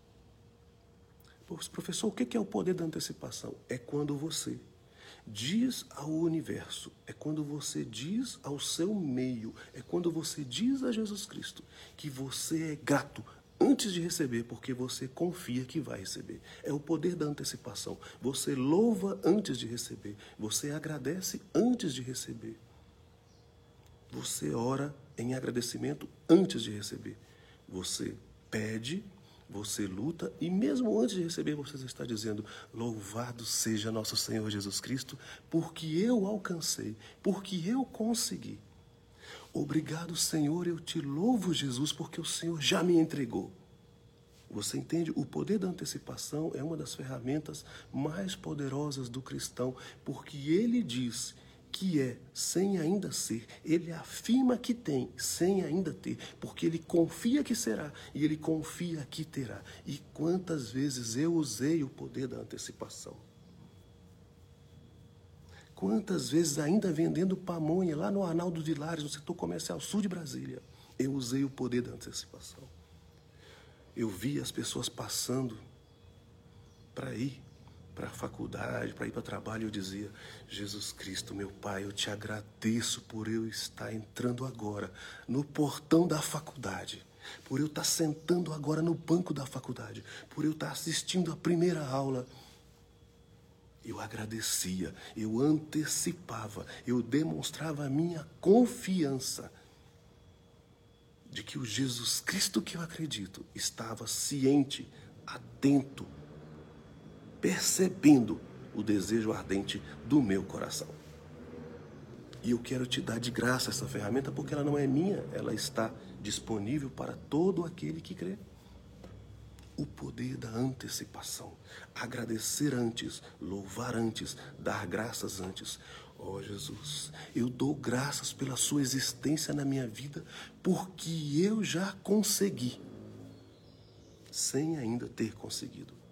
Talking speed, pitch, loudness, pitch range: 130 wpm, 135 Hz, -34 LUFS, 110-165 Hz